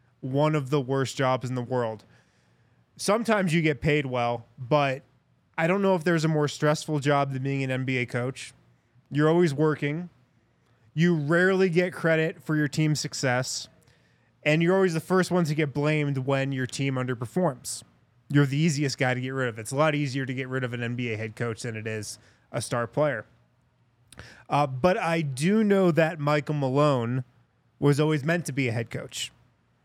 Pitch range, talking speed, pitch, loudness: 125-155 Hz, 190 wpm, 145 Hz, -26 LUFS